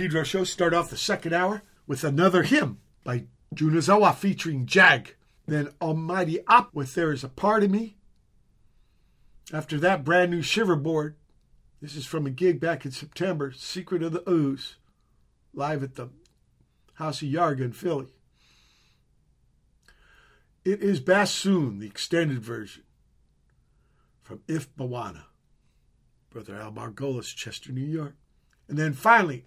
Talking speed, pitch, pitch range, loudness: 140 wpm, 150 Hz, 125-175 Hz, -25 LUFS